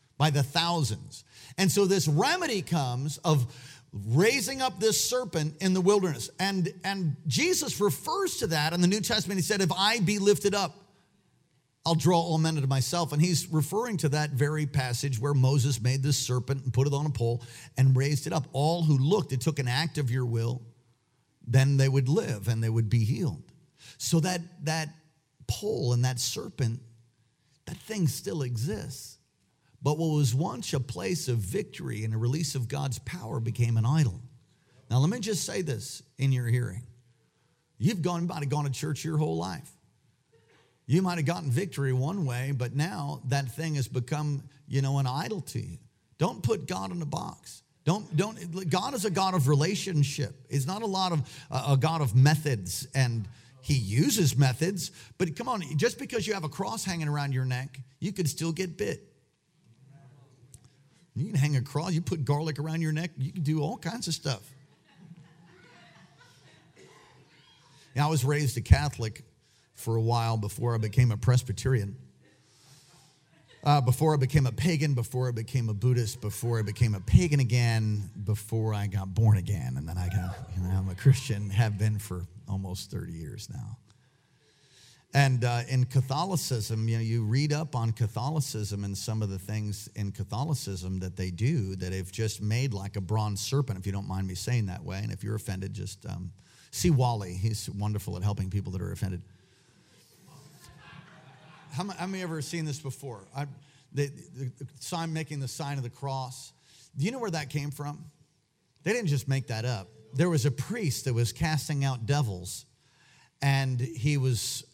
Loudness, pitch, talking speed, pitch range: -29 LUFS, 135 Hz, 185 wpm, 120-155 Hz